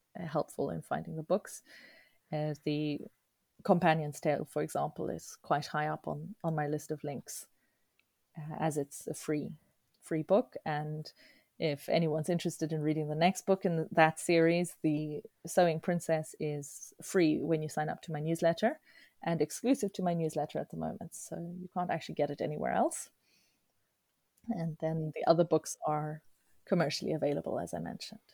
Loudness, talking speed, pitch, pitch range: -34 LUFS, 165 wpm, 160 Hz, 150-175 Hz